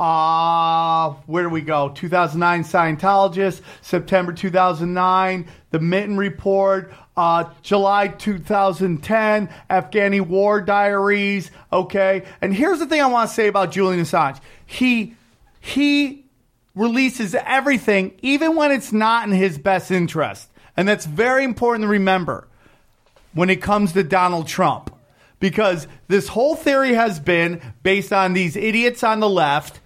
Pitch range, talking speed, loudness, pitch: 175-215 Hz, 135 wpm, -18 LUFS, 195 Hz